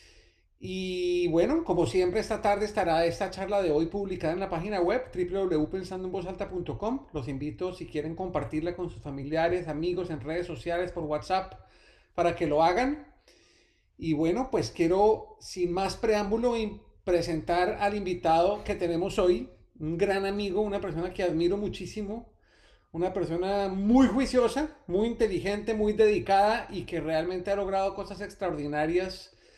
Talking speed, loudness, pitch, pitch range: 145 wpm, -29 LUFS, 185 Hz, 170-200 Hz